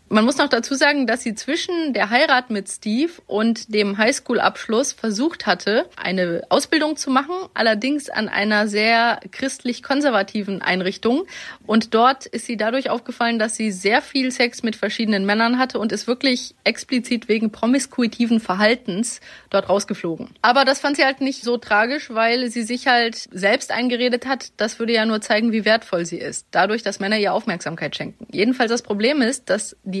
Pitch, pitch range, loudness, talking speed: 230 Hz, 210-255 Hz, -20 LUFS, 175 wpm